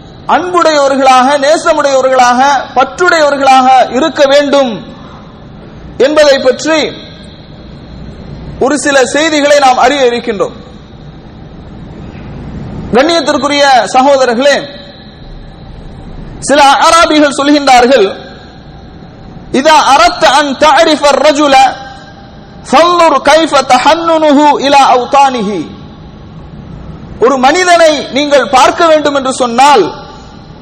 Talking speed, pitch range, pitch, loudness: 45 wpm, 265-315 Hz, 285 Hz, -7 LUFS